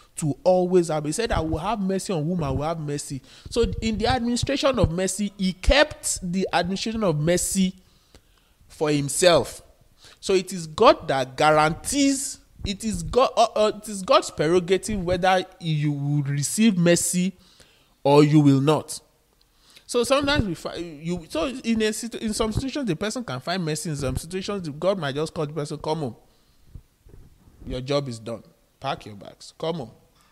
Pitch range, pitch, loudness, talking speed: 150-210 Hz, 175 Hz, -23 LUFS, 180 wpm